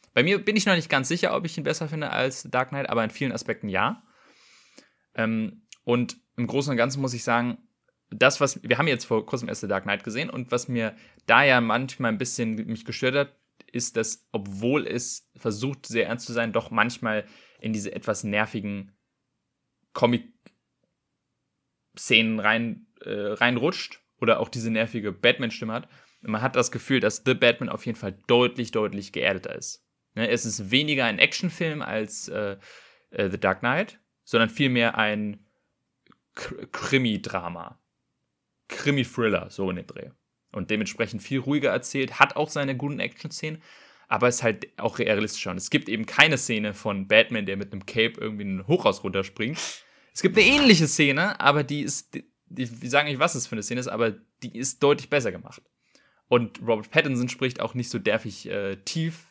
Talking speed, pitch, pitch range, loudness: 175 wpm, 120 Hz, 110-140 Hz, -24 LUFS